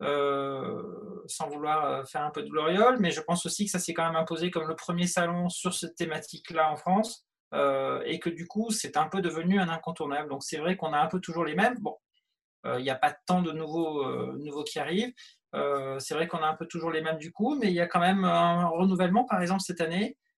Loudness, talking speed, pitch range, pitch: -29 LUFS, 250 wpm, 155-185 Hz, 170 Hz